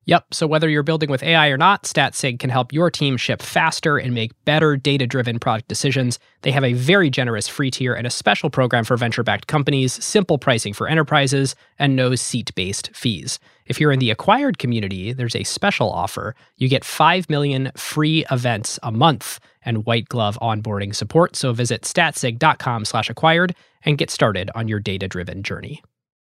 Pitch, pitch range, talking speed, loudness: 130 Hz, 115-150 Hz, 175 wpm, -19 LUFS